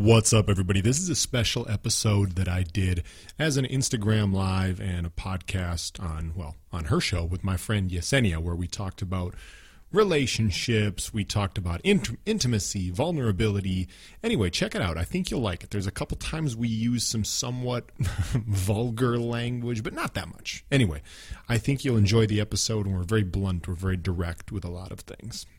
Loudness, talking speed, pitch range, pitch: -27 LUFS, 190 wpm, 90-120 Hz, 105 Hz